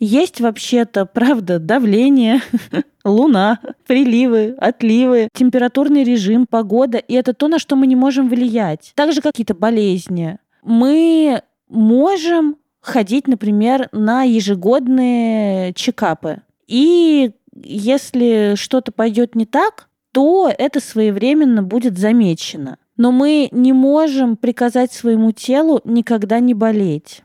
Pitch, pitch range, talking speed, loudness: 245 Hz, 220-270 Hz, 110 wpm, -14 LUFS